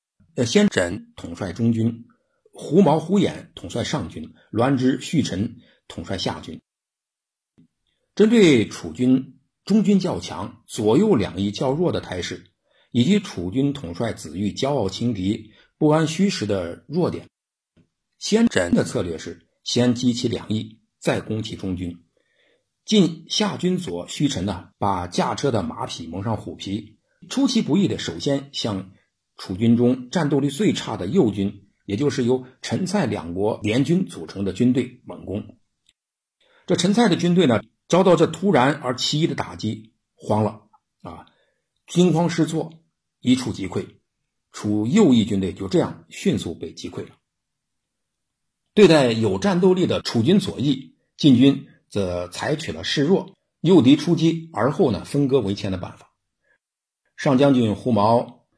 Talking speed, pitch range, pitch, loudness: 215 characters per minute, 100-165 Hz, 125 Hz, -21 LUFS